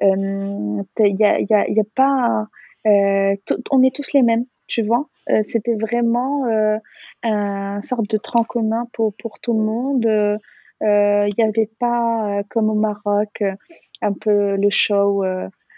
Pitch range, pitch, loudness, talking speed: 205-235 Hz, 215 Hz, -19 LUFS, 170 wpm